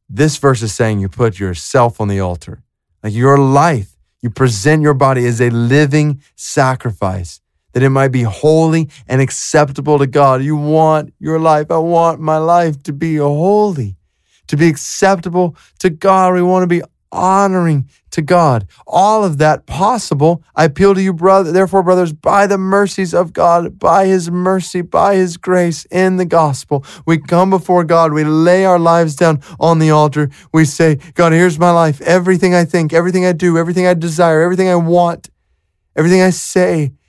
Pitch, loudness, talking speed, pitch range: 160 Hz, -12 LUFS, 180 wpm, 140-180 Hz